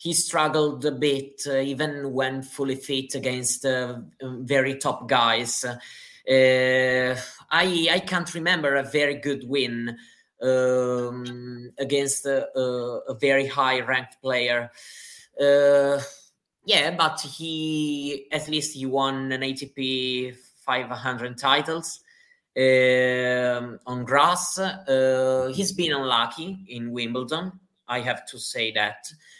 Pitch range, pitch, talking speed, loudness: 125-150 Hz, 135 Hz, 120 wpm, -24 LUFS